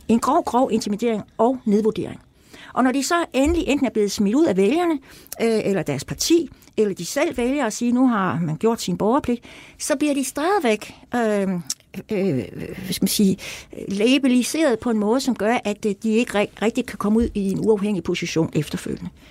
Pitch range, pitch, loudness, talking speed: 200-255 Hz, 225 Hz, -21 LUFS, 185 wpm